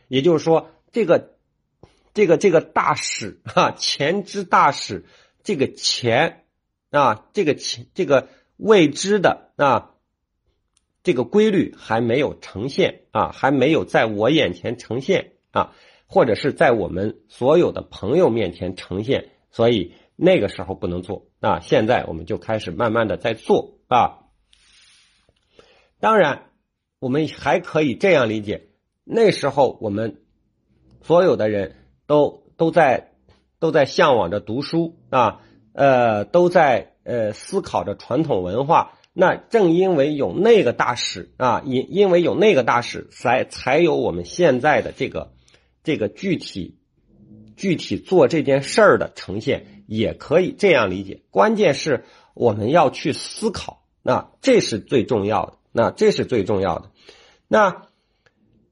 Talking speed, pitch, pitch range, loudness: 210 characters per minute, 125 Hz, 105-165 Hz, -19 LUFS